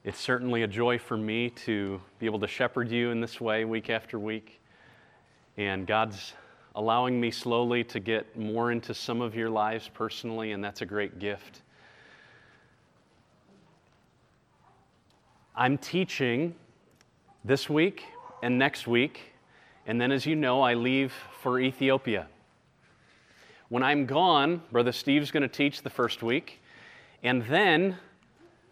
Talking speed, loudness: 140 wpm, -28 LUFS